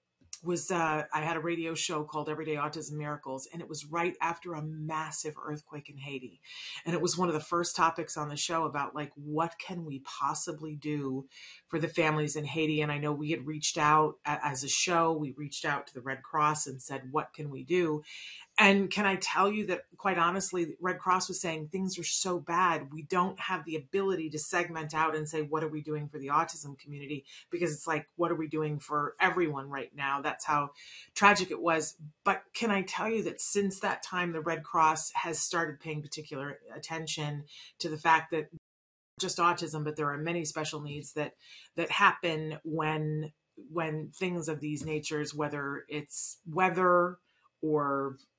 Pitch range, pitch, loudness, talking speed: 150-170 Hz, 155 Hz, -30 LUFS, 195 wpm